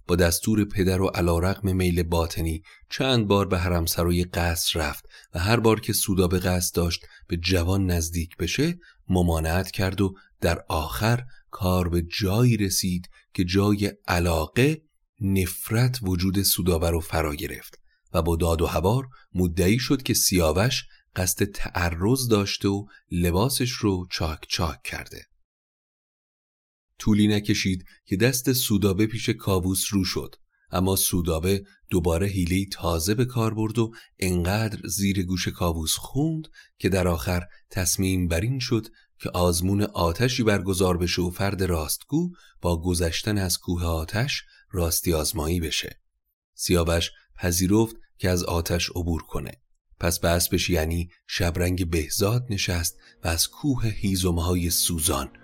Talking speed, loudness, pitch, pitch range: 135 wpm, -24 LUFS, 95 Hz, 85-105 Hz